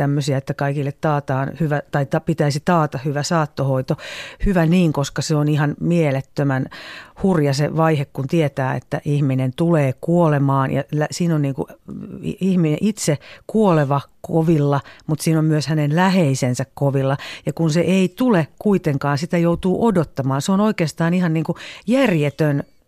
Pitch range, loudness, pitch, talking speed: 140-170 Hz, -19 LUFS, 155 Hz, 150 wpm